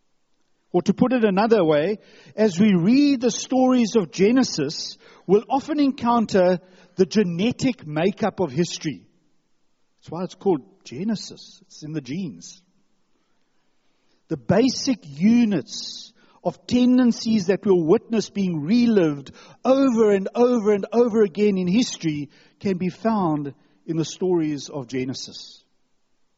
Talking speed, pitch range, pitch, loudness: 125 wpm, 175-235 Hz, 205 Hz, -21 LUFS